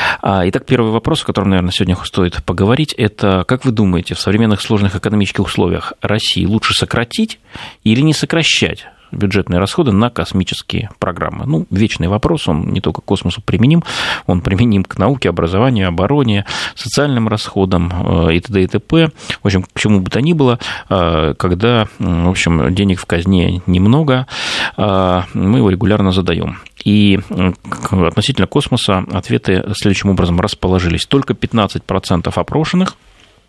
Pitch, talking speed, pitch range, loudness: 100 Hz, 140 wpm, 90-120 Hz, -14 LUFS